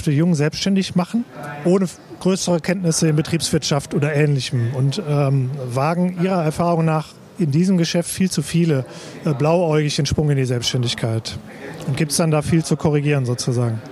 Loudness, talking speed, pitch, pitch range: -19 LUFS, 170 wpm, 155 Hz, 140-170 Hz